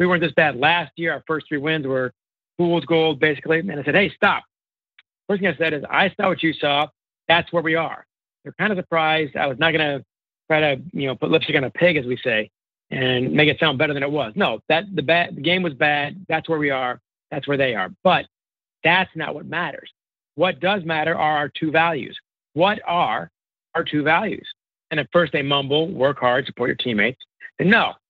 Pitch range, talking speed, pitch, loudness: 145-170 Hz, 230 wpm, 155 Hz, -20 LUFS